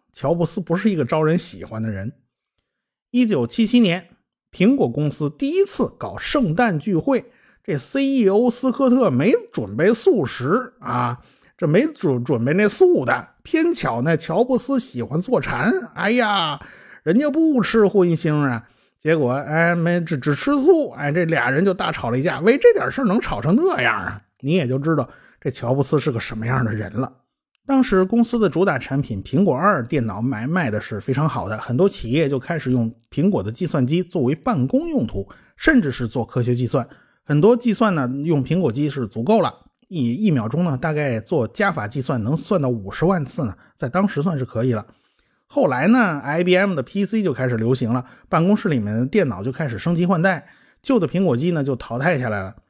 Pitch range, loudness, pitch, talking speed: 125-200 Hz, -20 LUFS, 155 Hz, 285 characters per minute